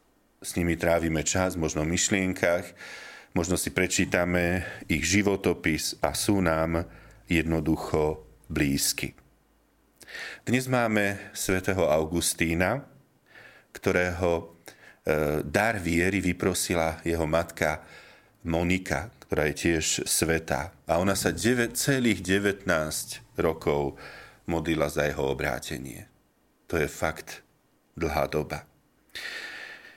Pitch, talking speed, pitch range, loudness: 85 Hz, 95 wpm, 80-95 Hz, -27 LUFS